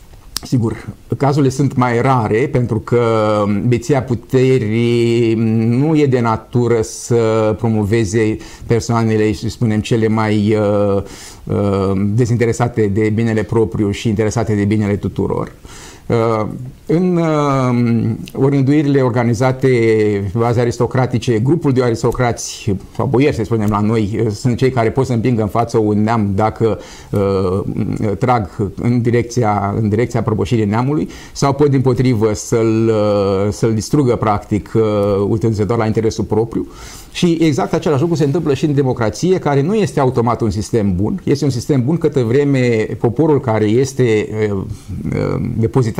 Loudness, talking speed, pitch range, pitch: -15 LUFS, 135 wpm, 110-130 Hz, 115 Hz